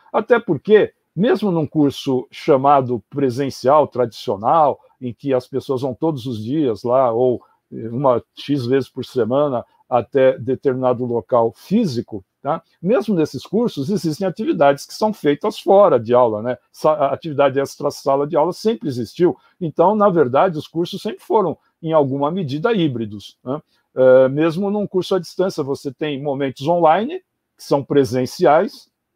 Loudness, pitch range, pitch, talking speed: -18 LUFS, 130-175 Hz, 145 Hz, 145 wpm